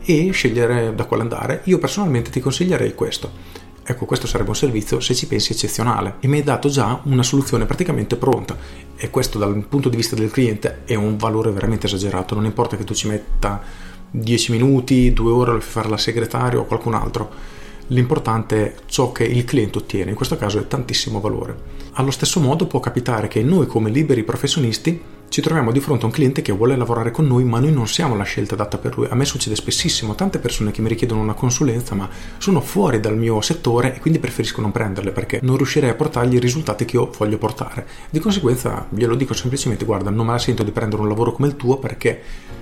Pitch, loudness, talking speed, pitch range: 120 Hz, -19 LUFS, 215 wpm, 110-135 Hz